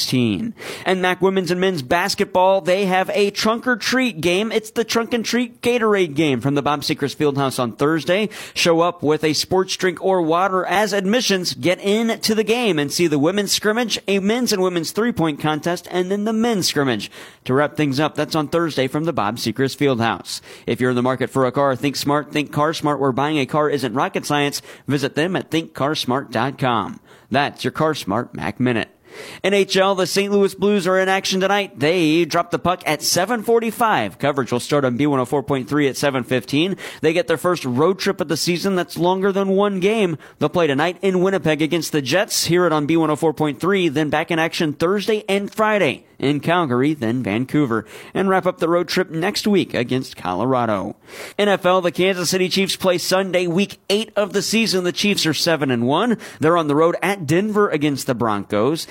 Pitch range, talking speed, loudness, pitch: 145-195 Hz, 200 wpm, -19 LUFS, 170 Hz